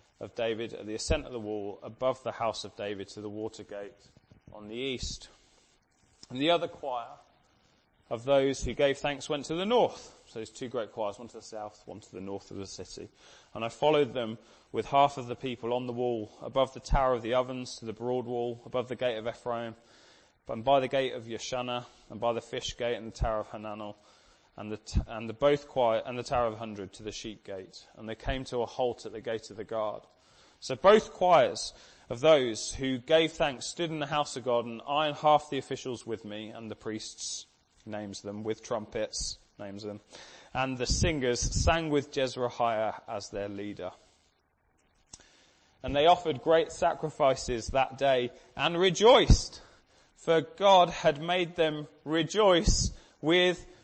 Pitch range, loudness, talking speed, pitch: 105-140 Hz, -30 LUFS, 195 wpm, 120 Hz